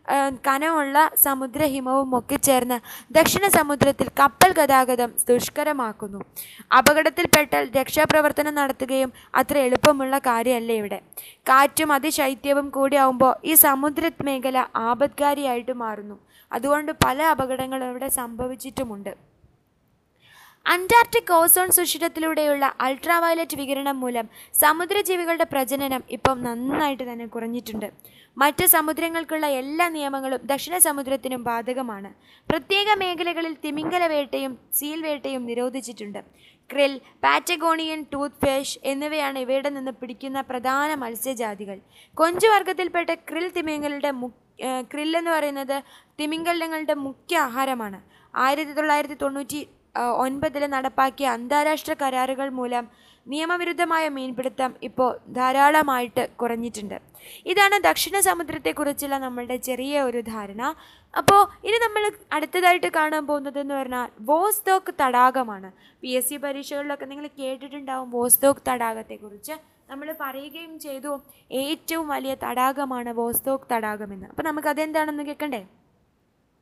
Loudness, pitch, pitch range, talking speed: -22 LUFS, 275 Hz, 255-310 Hz, 95 wpm